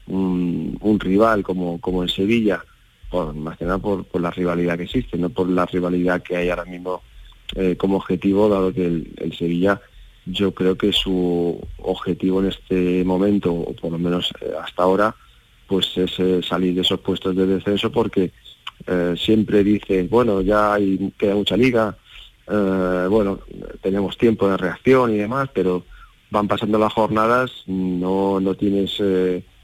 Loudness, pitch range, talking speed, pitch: -20 LUFS, 90-100 Hz, 170 wpm, 95 Hz